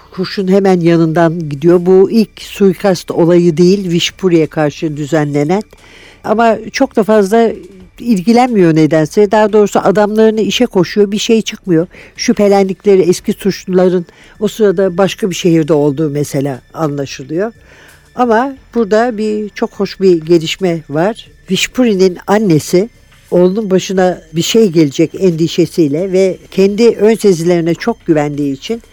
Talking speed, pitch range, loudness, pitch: 125 wpm, 170-215 Hz, -12 LUFS, 190 Hz